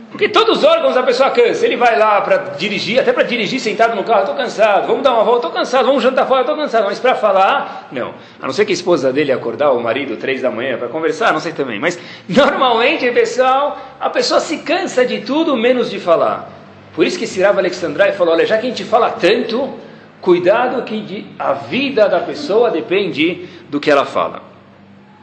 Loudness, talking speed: -15 LUFS, 210 wpm